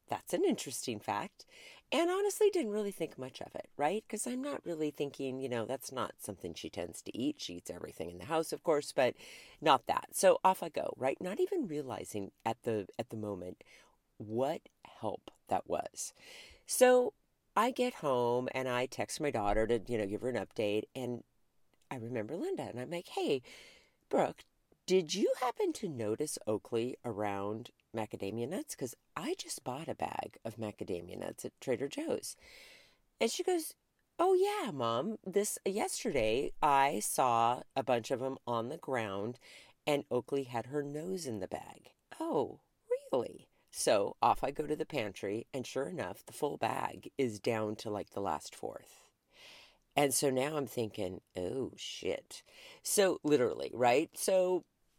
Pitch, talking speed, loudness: 145 Hz, 175 wpm, -35 LUFS